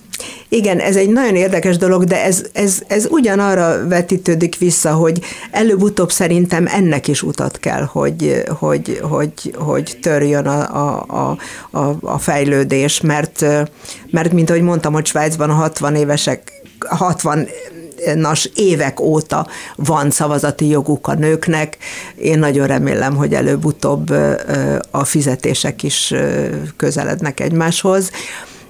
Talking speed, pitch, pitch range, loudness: 125 wpm, 160 Hz, 145-185 Hz, -15 LUFS